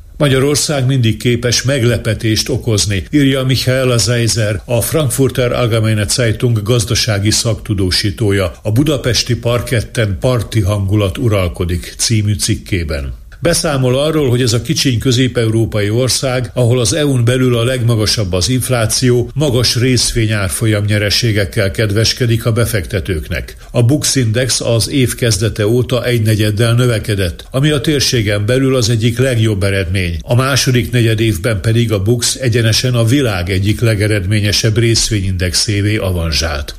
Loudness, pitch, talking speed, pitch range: -13 LUFS, 115 Hz, 120 wpm, 105-125 Hz